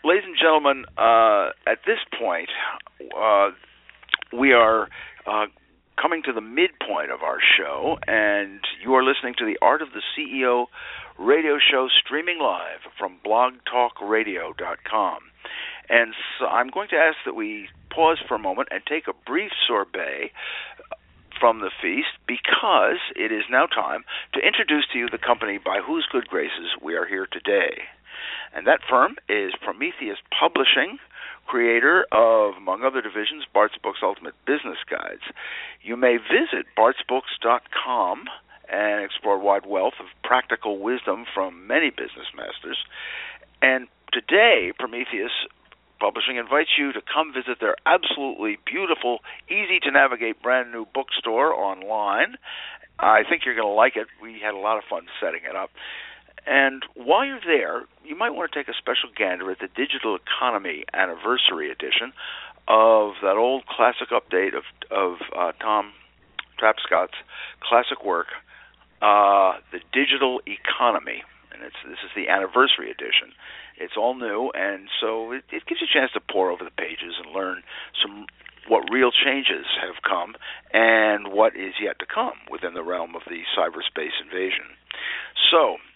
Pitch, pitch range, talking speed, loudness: 120 Hz, 105-155 Hz, 155 wpm, -22 LUFS